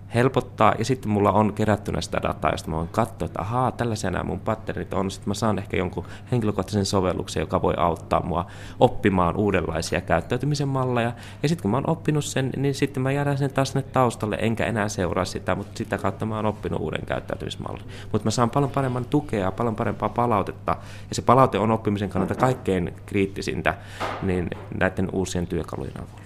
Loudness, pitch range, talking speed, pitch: -24 LUFS, 95-120 Hz, 190 wpm, 105 Hz